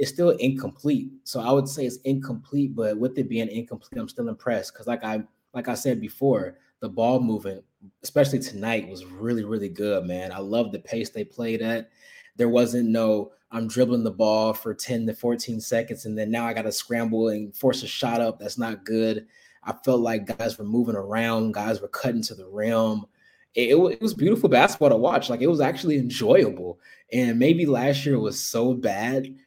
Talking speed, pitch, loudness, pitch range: 205 wpm, 115 Hz, -24 LUFS, 110-130 Hz